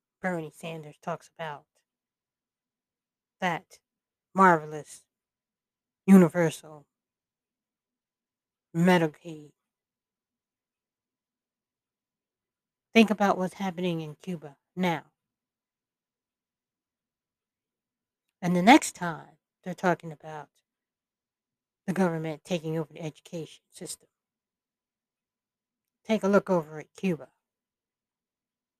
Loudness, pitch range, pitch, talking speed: -26 LUFS, 155-185 Hz, 170 Hz, 75 wpm